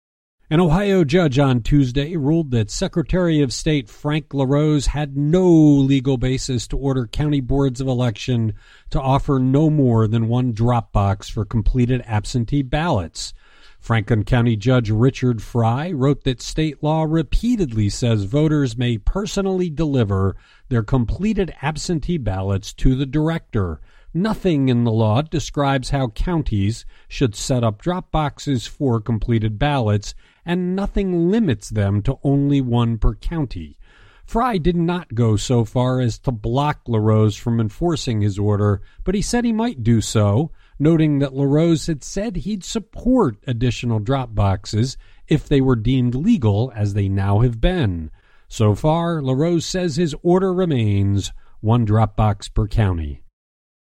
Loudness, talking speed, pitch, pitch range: -19 LUFS, 150 wpm, 130 Hz, 110-155 Hz